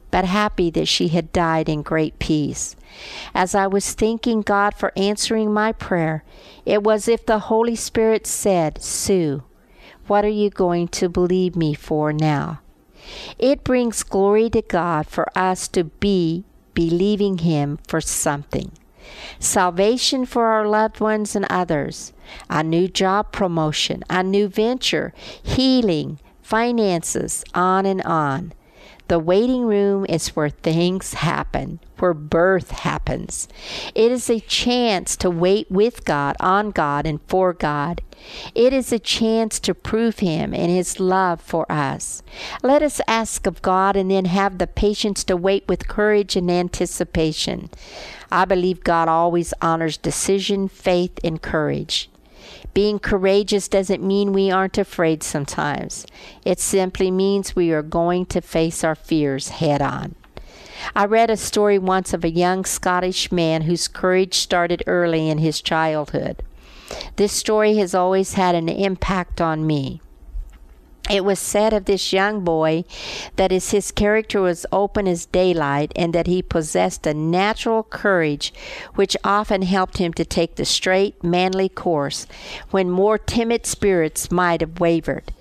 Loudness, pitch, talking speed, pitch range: -20 LUFS, 185 Hz, 150 wpm, 165-205 Hz